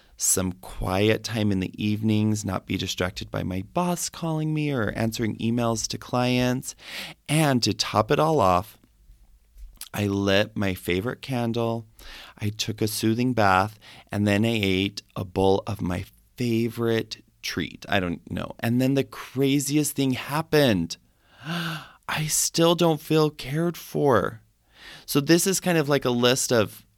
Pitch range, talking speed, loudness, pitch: 100-140 Hz, 155 wpm, -24 LUFS, 115 Hz